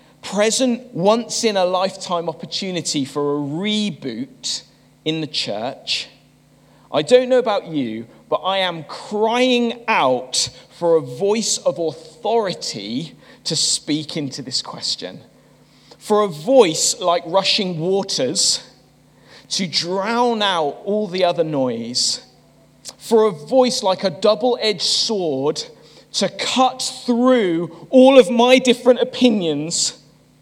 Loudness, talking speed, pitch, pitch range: -18 LUFS, 120 wpm, 190 Hz, 160-230 Hz